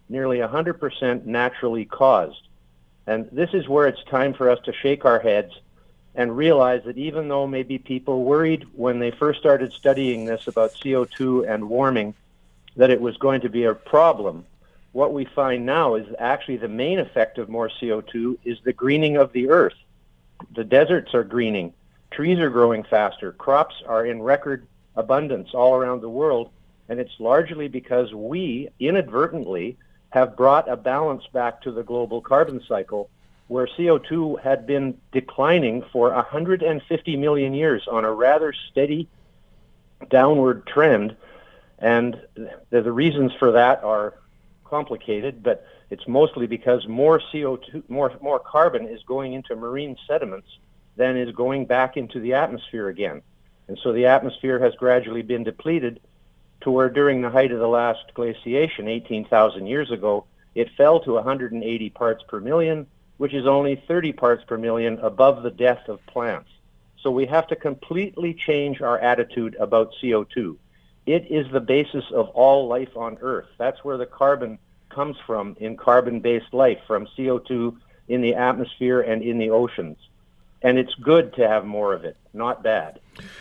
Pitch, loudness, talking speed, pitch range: 125 Hz, -21 LUFS, 160 wpm, 115-140 Hz